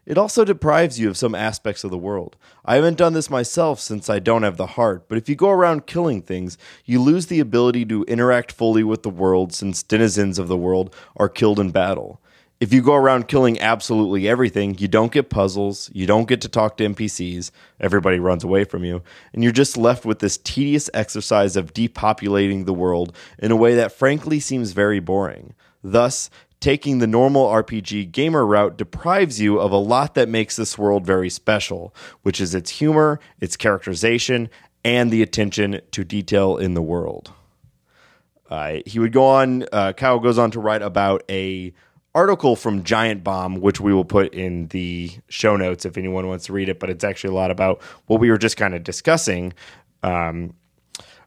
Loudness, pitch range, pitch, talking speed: -19 LUFS, 95-120 Hz, 105 Hz, 195 wpm